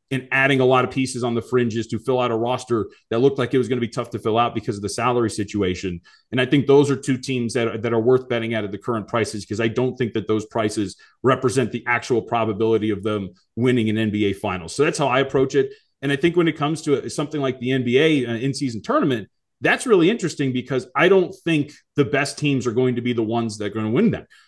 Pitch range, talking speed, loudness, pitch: 110-135 Hz, 265 wpm, -21 LUFS, 125 Hz